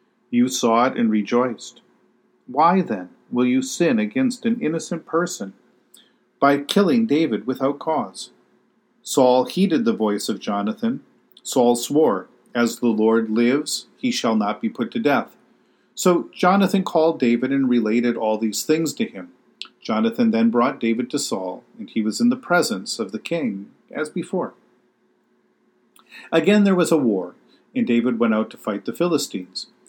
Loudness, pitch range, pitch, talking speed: -21 LUFS, 120-195 Hz, 150 Hz, 160 wpm